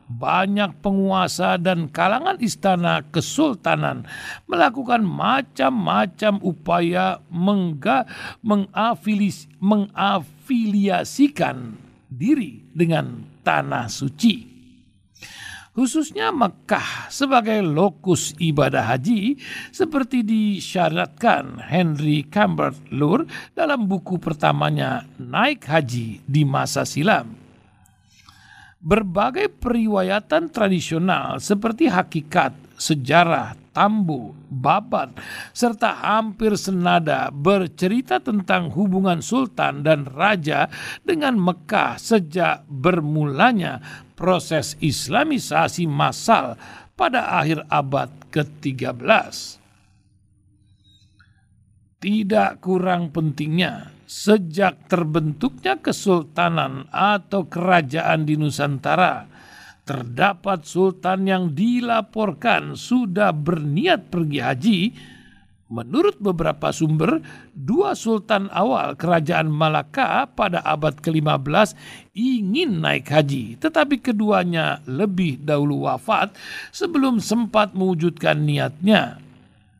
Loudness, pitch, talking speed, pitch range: -20 LUFS, 180 Hz, 80 wpm, 150-215 Hz